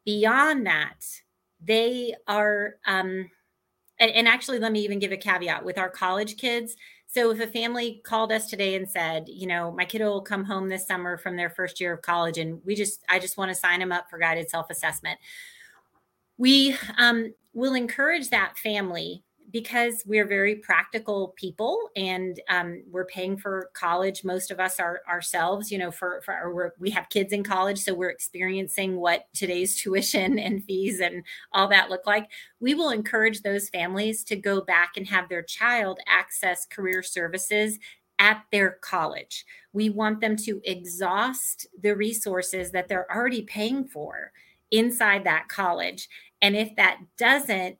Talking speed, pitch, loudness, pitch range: 175 wpm, 195 Hz, -25 LUFS, 185-220 Hz